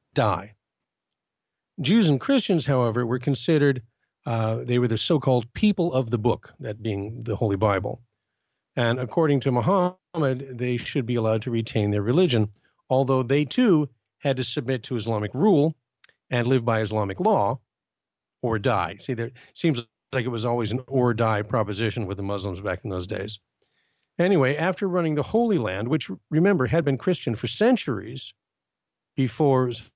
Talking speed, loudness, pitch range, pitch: 160 wpm, -24 LUFS, 110-145 Hz, 125 Hz